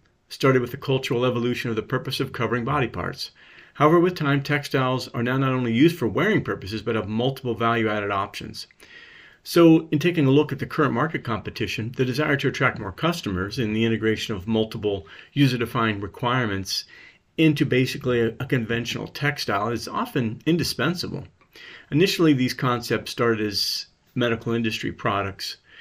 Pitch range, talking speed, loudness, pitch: 110-140 Hz, 160 wpm, -23 LUFS, 120 Hz